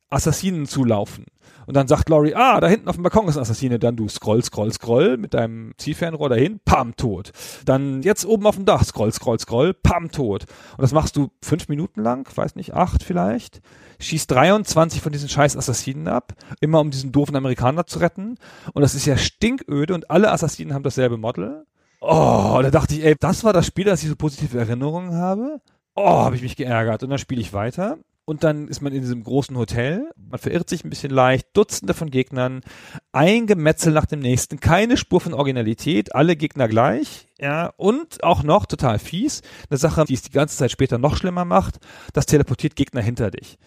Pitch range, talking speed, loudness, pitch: 125-170 Hz, 205 wpm, -20 LUFS, 145 Hz